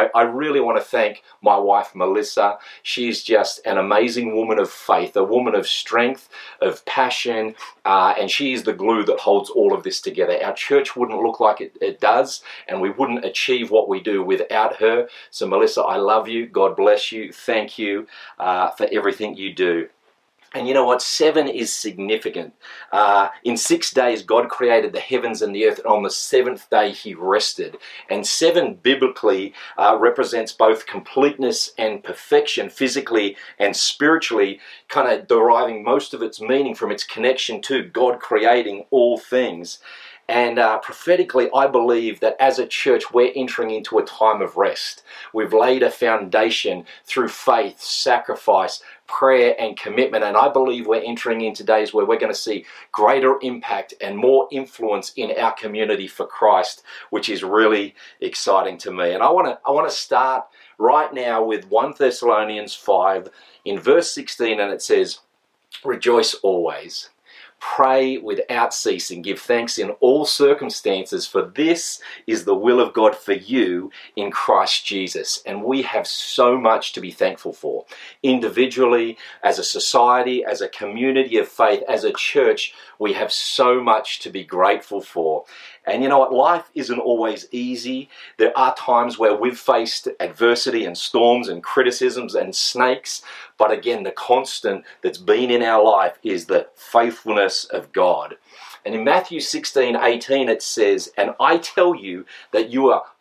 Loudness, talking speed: -19 LUFS, 170 wpm